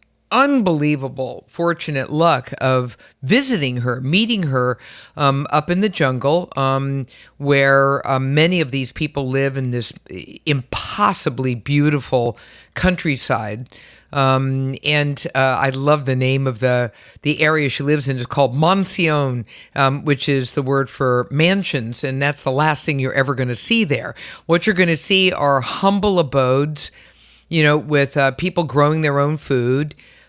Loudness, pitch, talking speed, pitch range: -18 LUFS, 140 Hz, 155 wpm, 130-155 Hz